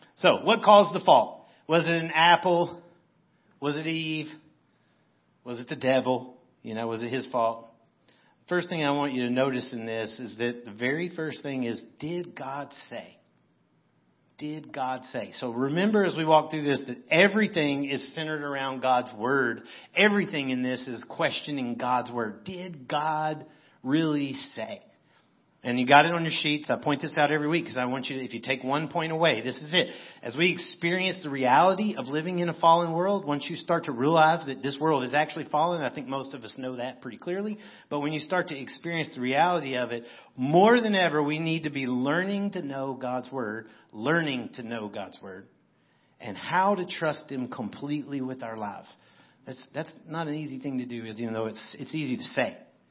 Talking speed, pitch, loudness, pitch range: 200 wpm, 145 Hz, -27 LUFS, 125-165 Hz